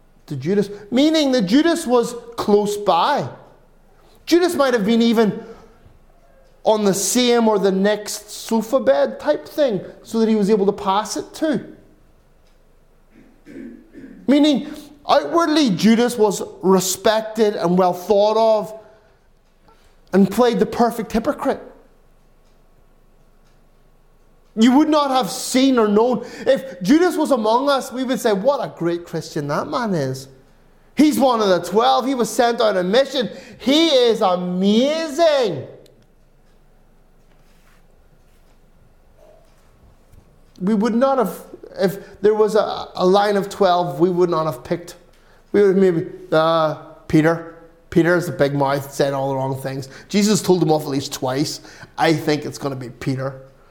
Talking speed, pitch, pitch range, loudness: 145 wpm, 215 Hz, 175-255 Hz, -18 LUFS